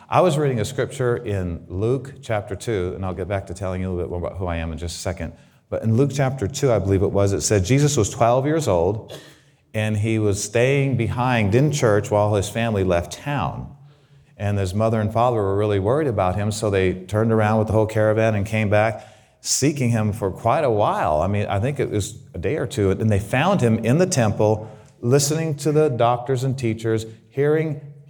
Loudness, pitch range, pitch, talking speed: -21 LUFS, 100-130 Hz, 110 Hz, 230 wpm